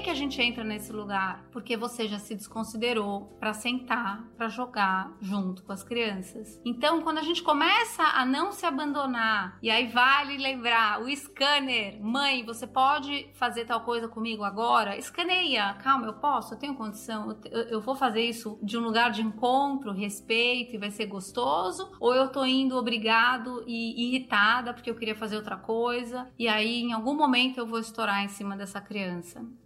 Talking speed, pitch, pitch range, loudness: 180 wpm, 235 Hz, 215-260 Hz, -27 LUFS